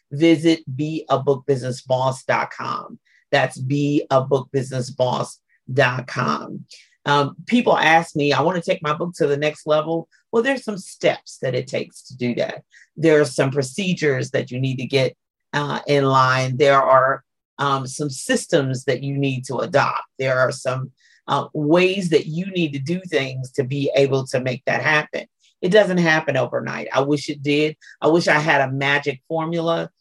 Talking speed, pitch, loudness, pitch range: 165 wpm, 145 Hz, -20 LUFS, 130-160 Hz